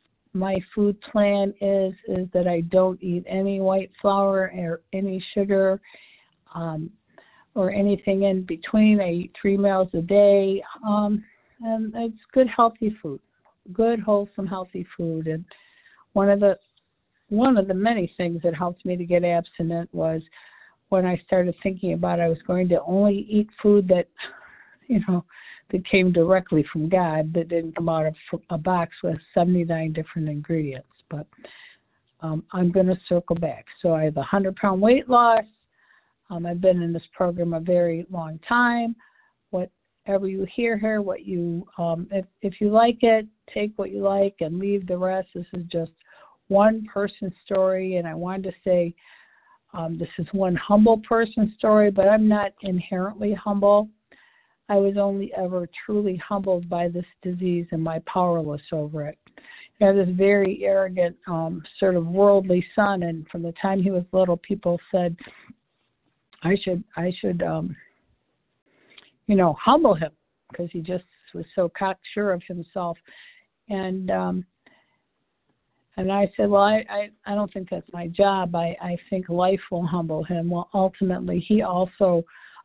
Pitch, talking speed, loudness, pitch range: 185 Hz, 165 wpm, -23 LUFS, 175-200 Hz